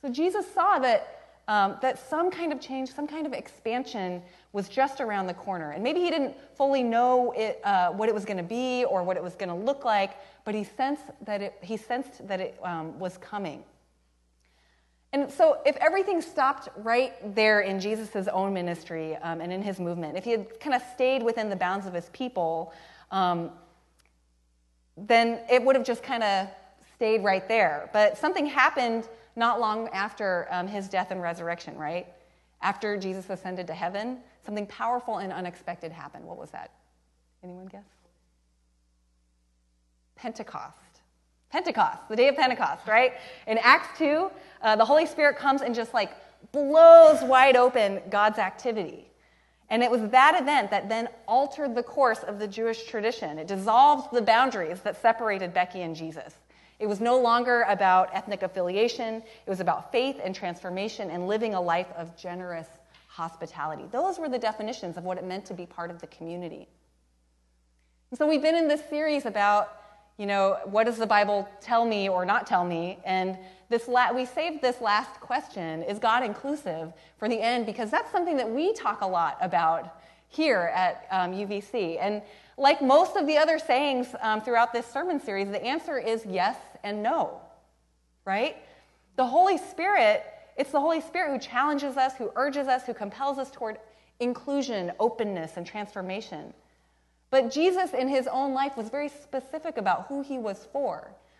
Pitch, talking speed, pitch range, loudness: 215 Hz, 180 wpm, 180-260 Hz, -26 LUFS